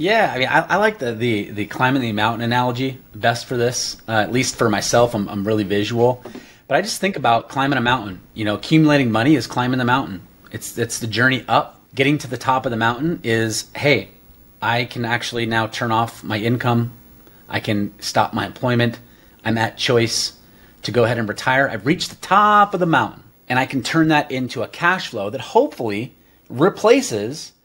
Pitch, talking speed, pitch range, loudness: 120 Hz, 205 wpm, 110-130 Hz, -19 LUFS